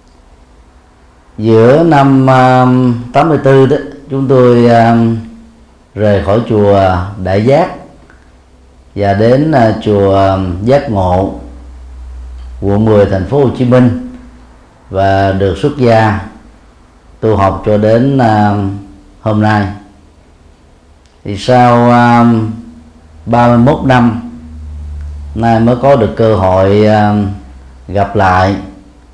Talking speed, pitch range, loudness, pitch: 105 wpm, 80-120 Hz, -9 LUFS, 100 Hz